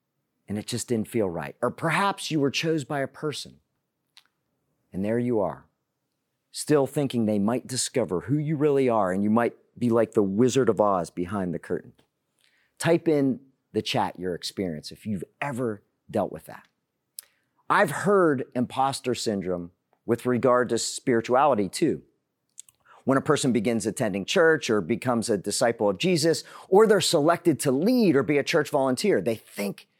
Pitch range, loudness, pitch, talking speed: 115-150 Hz, -25 LUFS, 125 Hz, 170 wpm